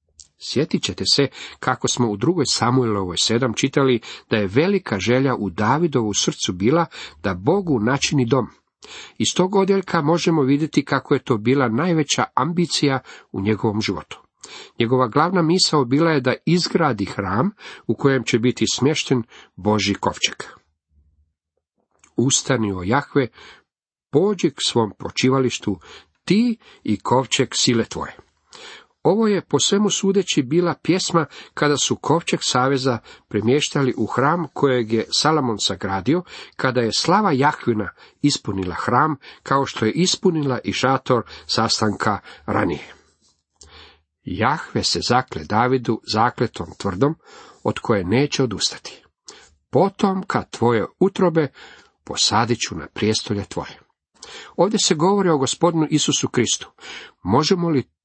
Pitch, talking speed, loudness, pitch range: 130 Hz, 125 wpm, -20 LUFS, 110-160 Hz